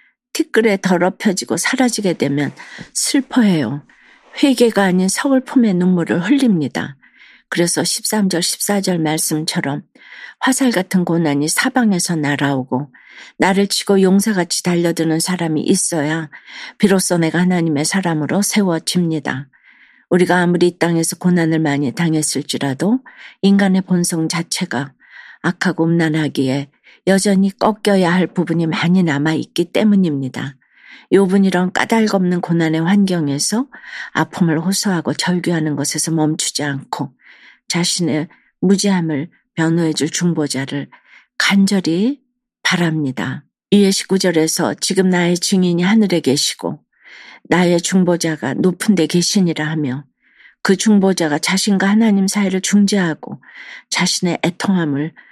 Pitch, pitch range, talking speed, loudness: 175 Hz, 160-195 Hz, 290 characters per minute, -16 LUFS